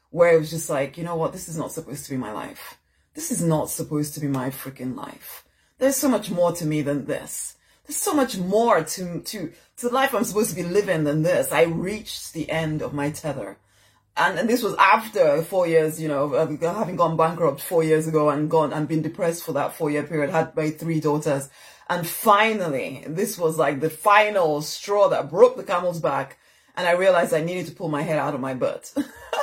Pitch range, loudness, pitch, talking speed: 150-185 Hz, -23 LUFS, 160 Hz, 225 wpm